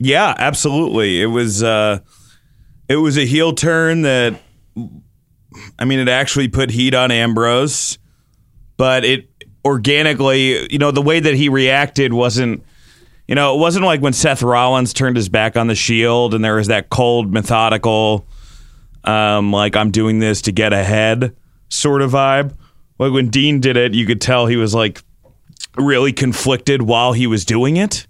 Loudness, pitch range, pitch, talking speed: -14 LUFS, 110-135 Hz, 125 Hz, 170 wpm